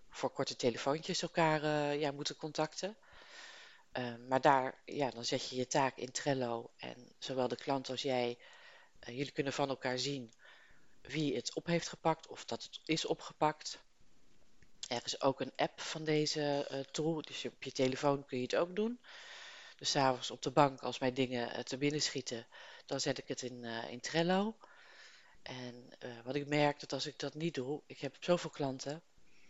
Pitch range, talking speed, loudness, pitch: 130-155 Hz, 195 wpm, -37 LUFS, 140 Hz